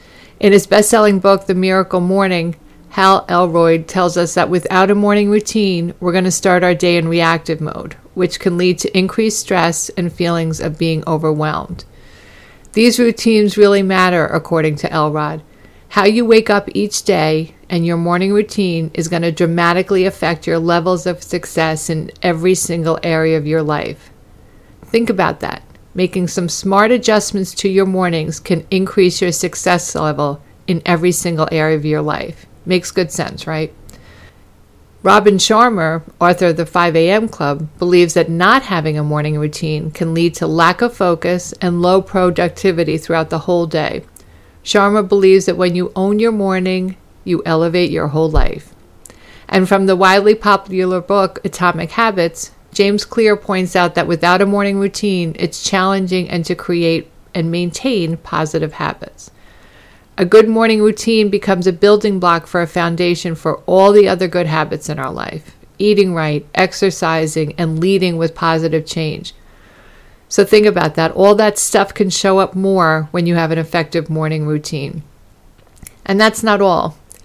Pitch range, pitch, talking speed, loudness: 160-195 Hz, 175 Hz, 165 wpm, -14 LUFS